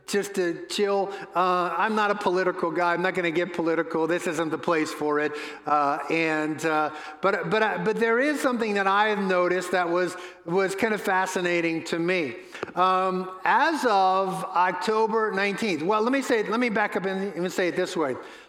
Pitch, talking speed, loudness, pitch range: 185 Hz, 195 wpm, -25 LUFS, 170-210 Hz